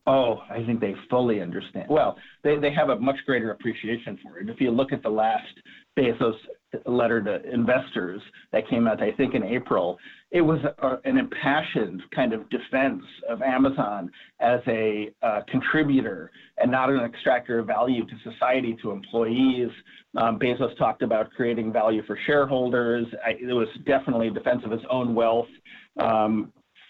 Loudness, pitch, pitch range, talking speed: -25 LUFS, 125 Hz, 115-140 Hz, 170 wpm